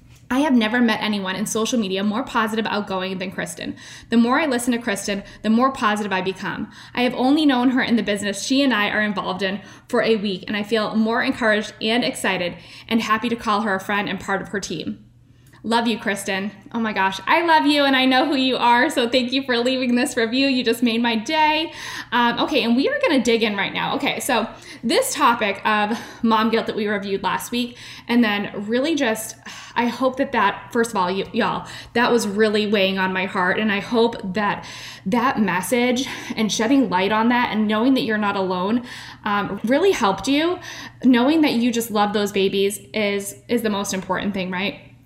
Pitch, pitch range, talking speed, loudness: 220 Hz, 200-245 Hz, 220 wpm, -20 LUFS